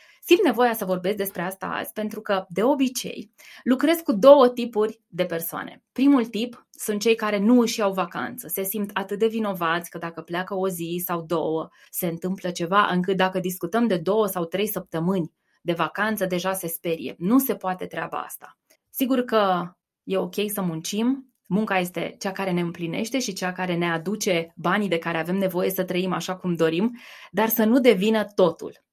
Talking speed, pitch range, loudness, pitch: 190 wpm, 180-220 Hz, -24 LUFS, 190 Hz